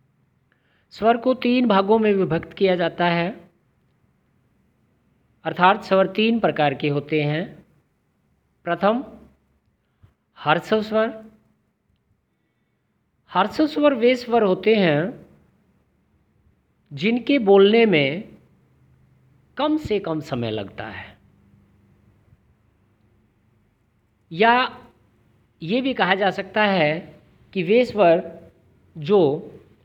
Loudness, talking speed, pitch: -20 LUFS, 85 wpm, 175 Hz